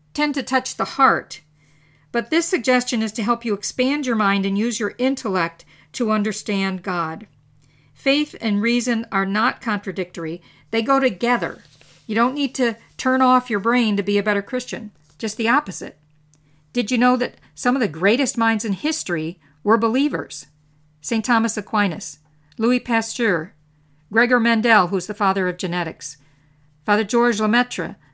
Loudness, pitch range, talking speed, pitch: -20 LUFS, 170-240 Hz, 160 wpm, 210 Hz